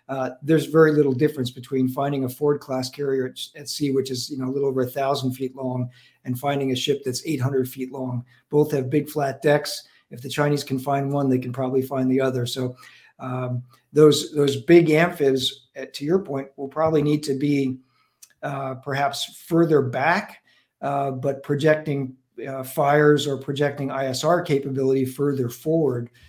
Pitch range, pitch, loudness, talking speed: 130-145 Hz, 135 Hz, -23 LUFS, 180 wpm